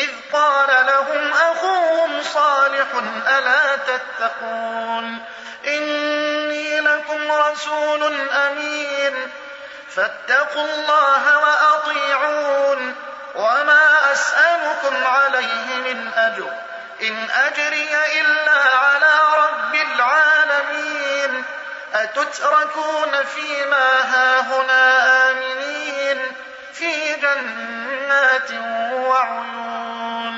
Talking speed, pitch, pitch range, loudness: 60 wpm, 285 Hz, 260-300 Hz, -17 LUFS